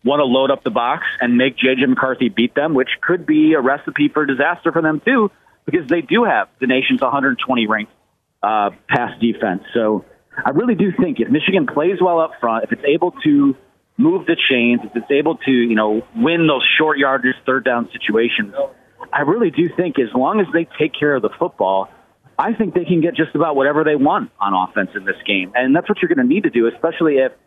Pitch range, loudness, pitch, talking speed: 120-170 Hz, -17 LUFS, 140 Hz, 225 wpm